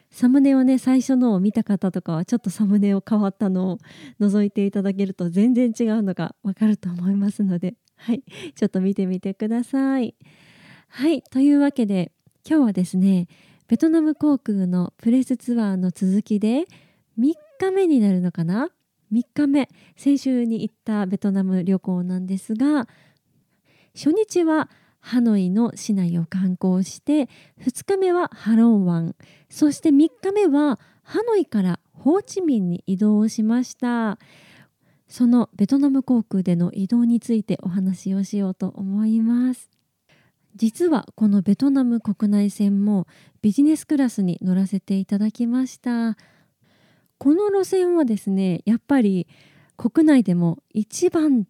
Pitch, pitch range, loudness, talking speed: 215 Hz, 190-260 Hz, -21 LUFS, 290 characters per minute